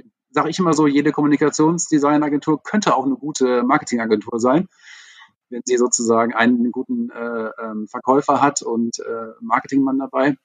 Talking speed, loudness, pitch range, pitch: 145 wpm, -19 LUFS, 120-150 Hz, 135 Hz